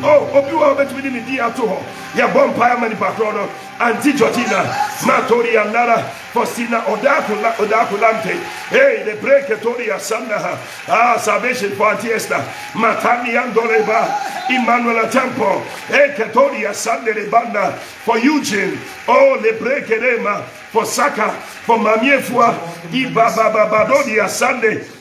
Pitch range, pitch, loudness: 220-280 Hz, 235 Hz, -15 LUFS